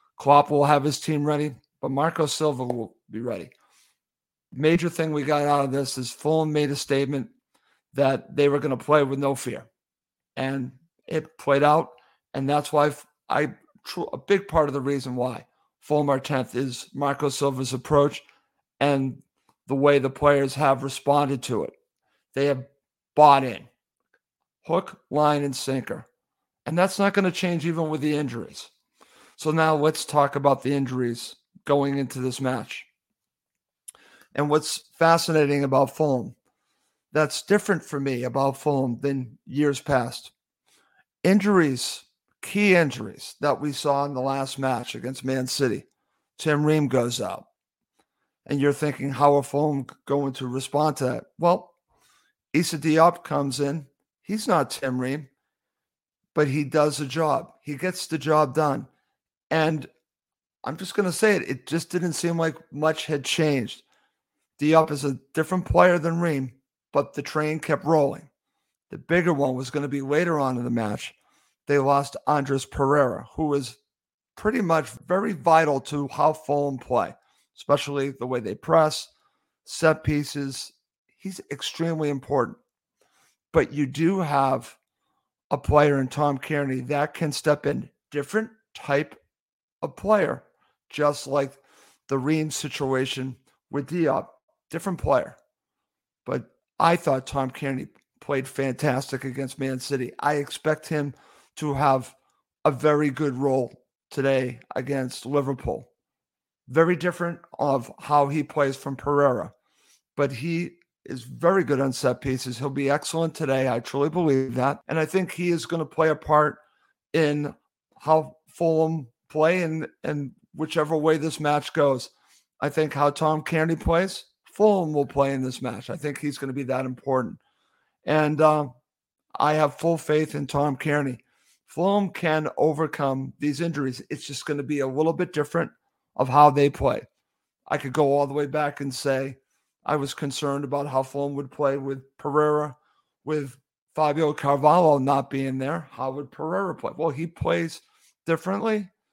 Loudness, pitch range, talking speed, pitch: -24 LUFS, 135-155 Hz, 155 wpm, 145 Hz